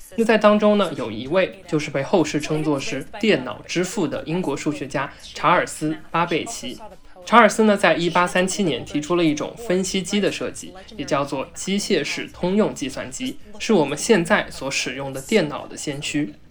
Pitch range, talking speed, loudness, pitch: 150-205 Hz, 270 characters per minute, -21 LUFS, 175 Hz